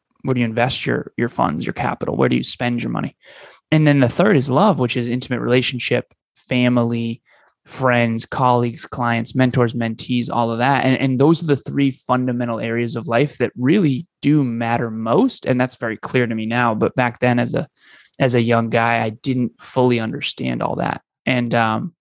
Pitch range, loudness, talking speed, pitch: 115-130 Hz, -19 LUFS, 200 wpm, 120 Hz